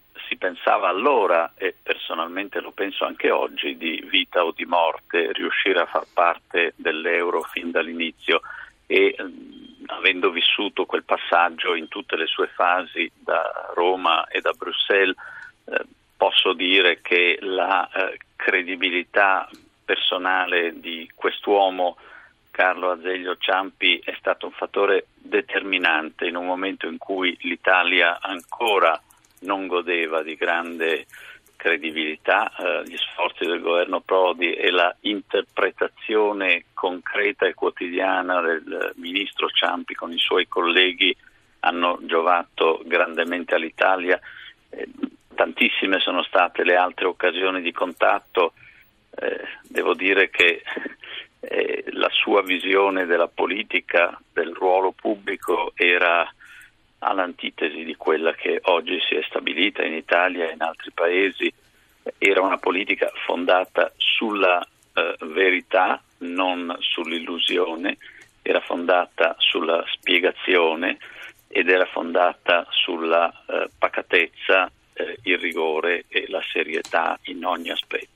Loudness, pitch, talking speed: -21 LUFS, 345 Hz, 120 wpm